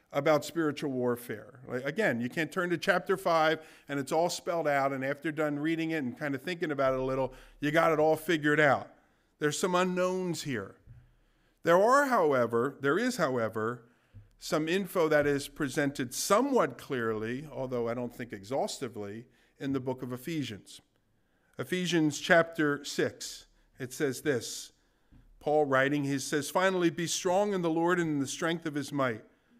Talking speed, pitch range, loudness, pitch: 170 wpm, 130-165 Hz, -30 LUFS, 145 Hz